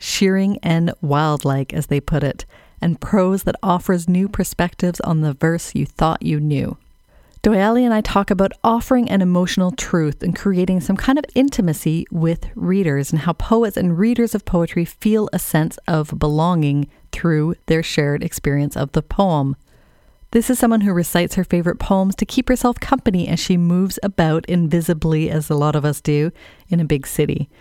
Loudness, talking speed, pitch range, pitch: -18 LUFS, 180 wpm, 155-195 Hz, 175 Hz